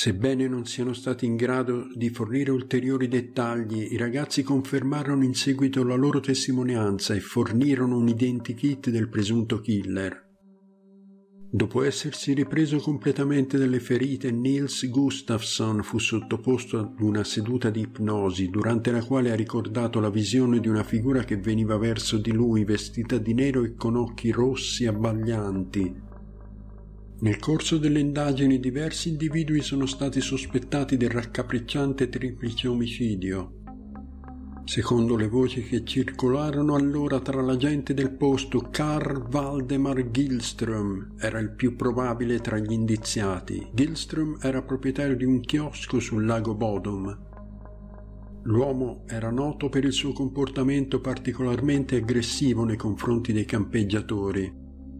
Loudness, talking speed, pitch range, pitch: -26 LUFS, 130 wpm, 110-135 Hz, 125 Hz